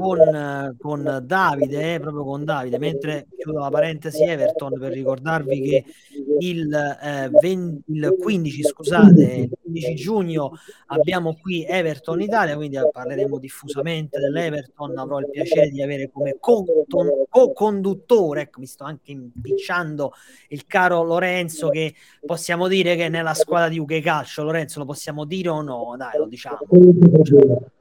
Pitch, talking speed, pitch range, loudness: 155 Hz, 150 wpm, 145-170 Hz, -19 LUFS